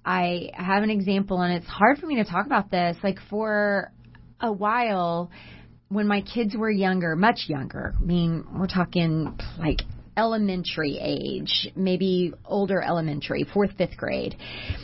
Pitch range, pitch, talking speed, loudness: 175-210 Hz, 190 Hz, 150 wpm, -25 LUFS